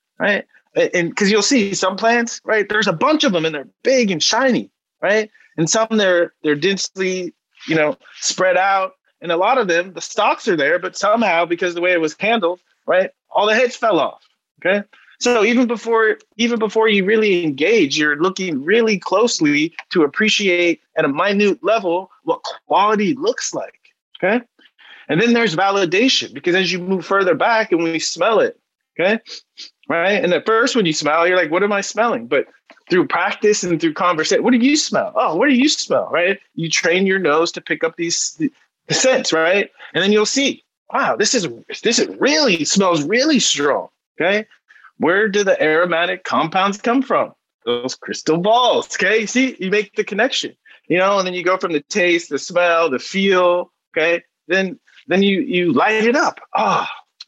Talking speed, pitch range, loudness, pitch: 190 wpm, 175-235 Hz, -17 LUFS, 195 Hz